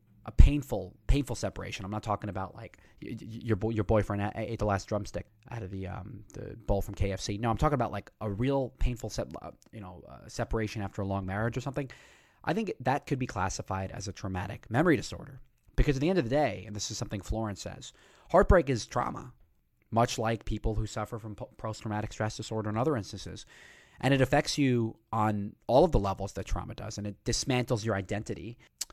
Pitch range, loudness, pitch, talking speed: 100-120 Hz, -31 LUFS, 110 Hz, 210 wpm